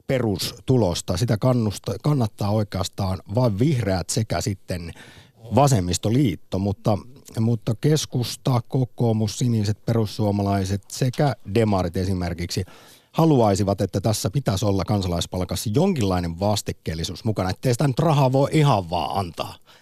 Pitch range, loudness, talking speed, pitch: 95-125 Hz, -23 LUFS, 110 wpm, 110 Hz